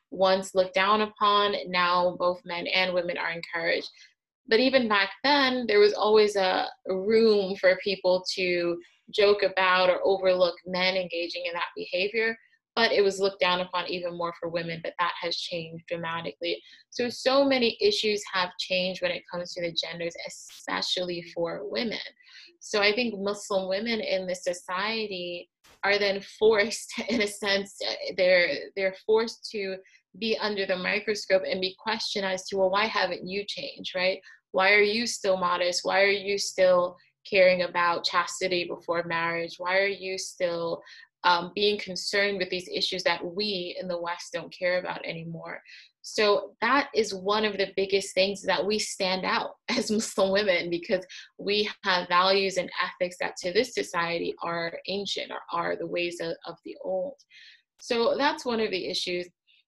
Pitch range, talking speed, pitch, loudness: 180-205 Hz, 170 wpm, 190 Hz, -26 LUFS